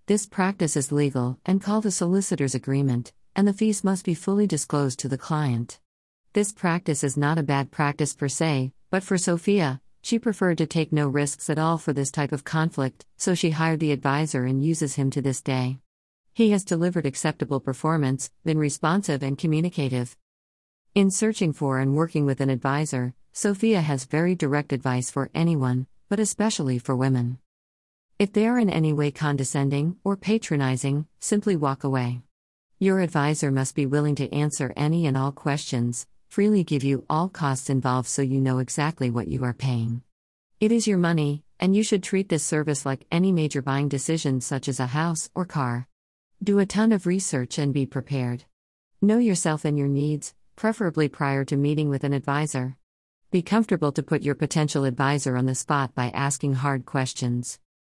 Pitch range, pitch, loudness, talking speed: 135-170 Hz, 145 Hz, -25 LUFS, 180 wpm